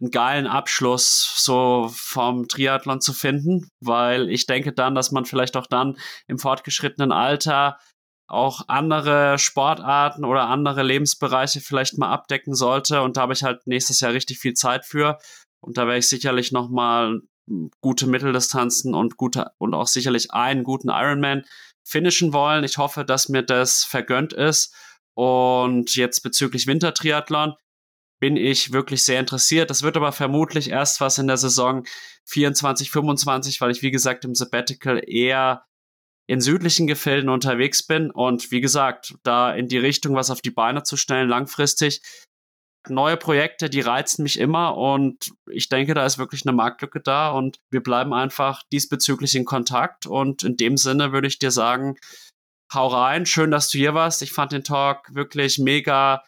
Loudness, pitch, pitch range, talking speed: -20 LUFS, 135 Hz, 125-145 Hz, 165 wpm